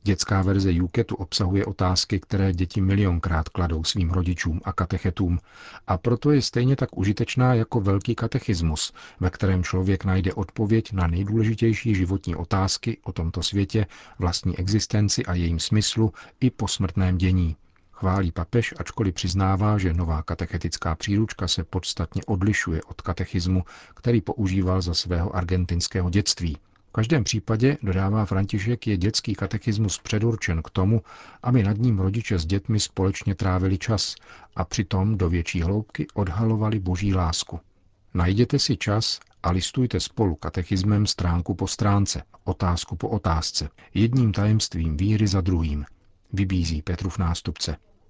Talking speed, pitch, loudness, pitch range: 140 wpm, 95 Hz, -24 LUFS, 90-110 Hz